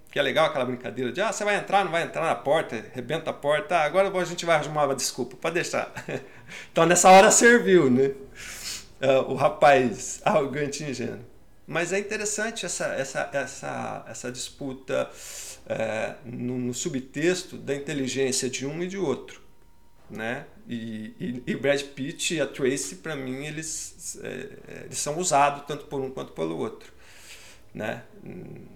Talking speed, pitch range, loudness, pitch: 165 wpm, 130-180 Hz, -25 LUFS, 145 Hz